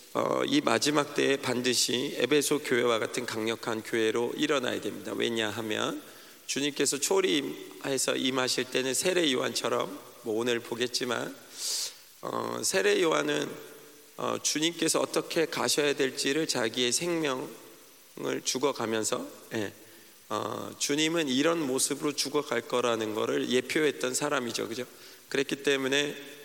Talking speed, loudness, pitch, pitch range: 290 characters per minute, -29 LUFS, 140 Hz, 120-155 Hz